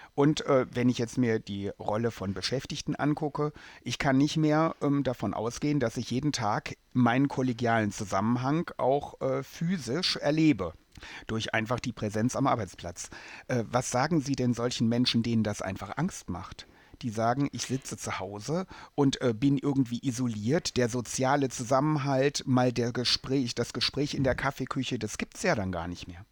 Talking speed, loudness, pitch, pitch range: 175 wpm, -29 LUFS, 125 Hz, 115-140 Hz